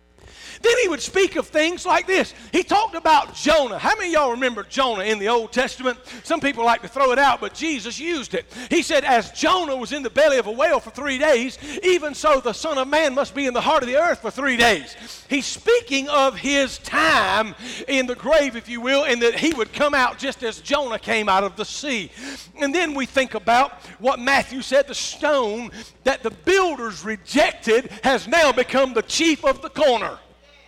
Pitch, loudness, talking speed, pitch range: 270 Hz, -20 LUFS, 215 wpm, 235-305 Hz